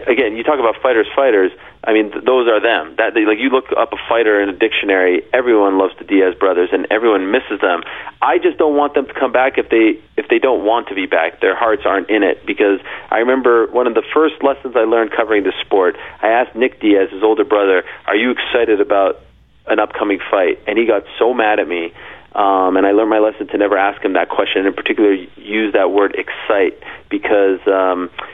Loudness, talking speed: -15 LUFS, 230 wpm